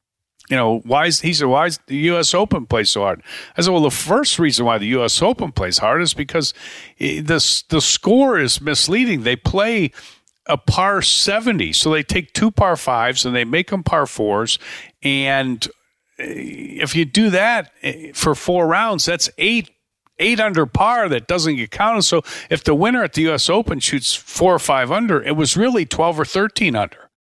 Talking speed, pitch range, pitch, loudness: 190 wpm, 140-200 Hz, 165 Hz, -17 LUFS